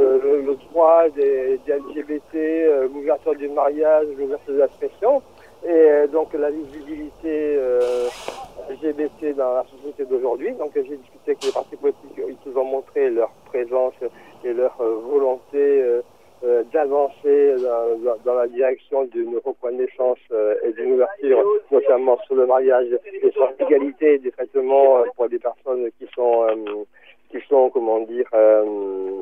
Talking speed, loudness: 160 wpm, -20 LUFS